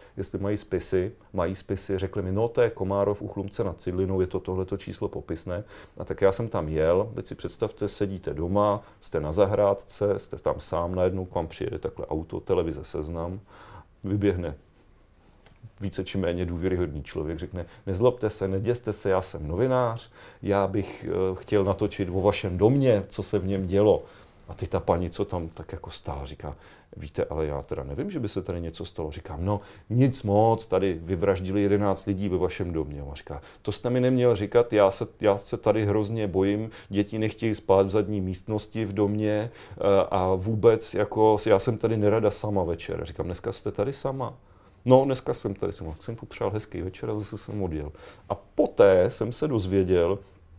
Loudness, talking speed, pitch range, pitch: -27 LUFS, 185 wpm, 95-110 Hz, 100 Hz